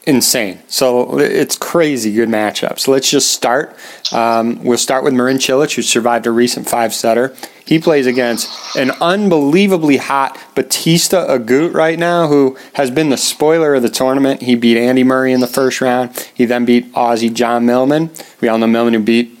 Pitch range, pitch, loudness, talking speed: 120-140 Hz, 130 Hz, -13 LUFS, 180 wpm